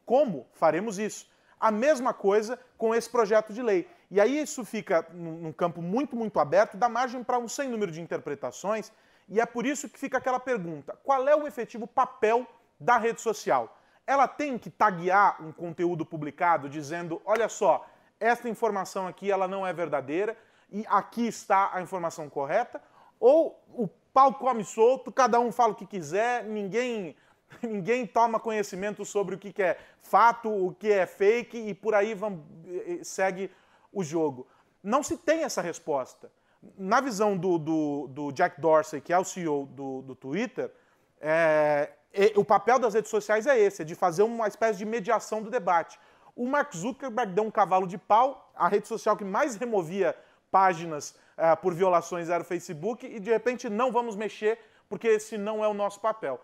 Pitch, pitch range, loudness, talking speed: 215 Hz, 185-235 Hz, -27 LUFS, 180 wpm